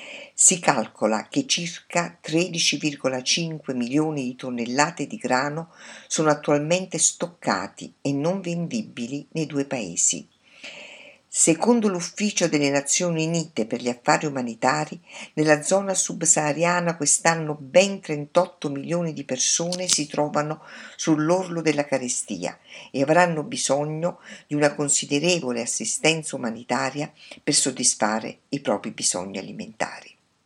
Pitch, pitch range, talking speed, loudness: 155 Hz, 140-175 Hz, 110 wpm, -23 LUFS